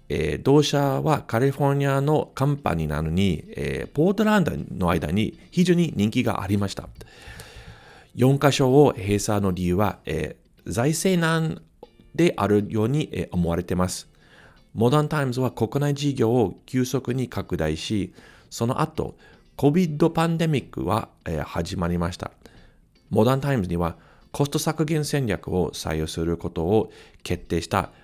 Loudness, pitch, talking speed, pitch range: -23 LUFS, 125 Hz, 280 characters per minute, 90-145 Hz